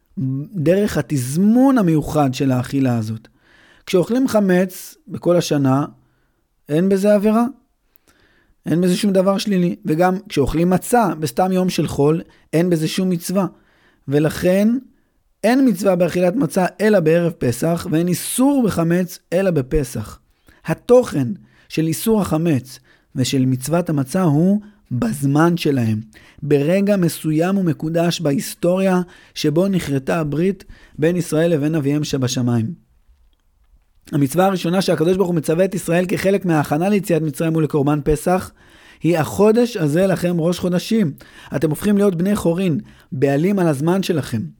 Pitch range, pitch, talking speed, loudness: 145-190 Hz, 170 Hz, 125 wpm, -18 LUFS